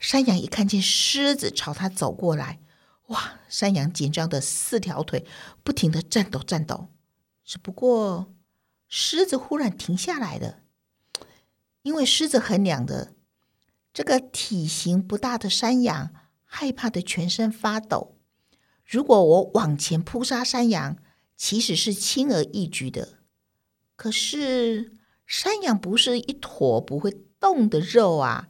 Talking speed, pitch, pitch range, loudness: 195 characters per minute, 205 Hz, 170-245 Hz, -23 LUFS